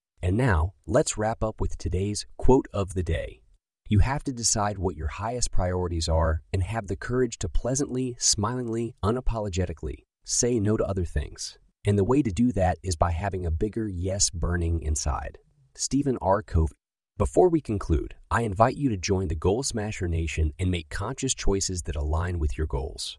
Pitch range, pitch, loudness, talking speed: 85-115 Hz, 95 Hz, -27 LUFS, 185 wpm